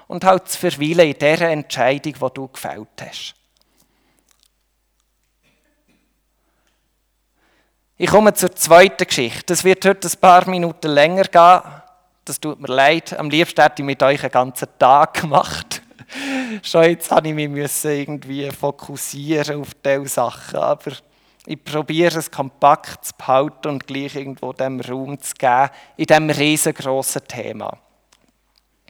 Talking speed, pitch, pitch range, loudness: 135 wpm, 150 Hz, 140-175 Hz, -16 LUFS